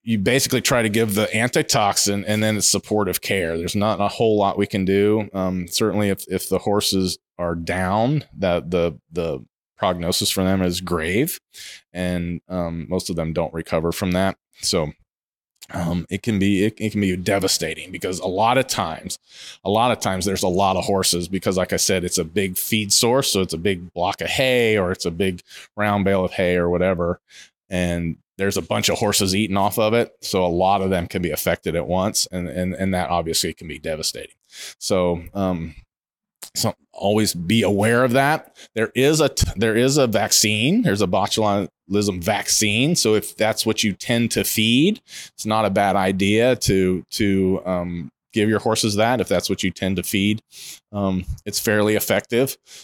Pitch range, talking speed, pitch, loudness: 90-110 Hz, 200 wpm, 100 Hz, -20 LUFS